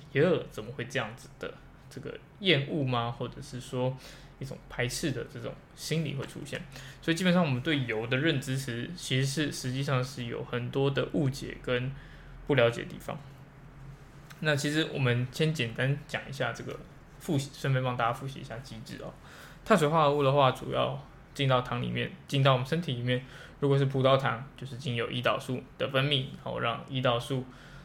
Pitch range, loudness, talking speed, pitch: 125-145 Hz, -30 LUFS, 295 characters per minute, 135 Hz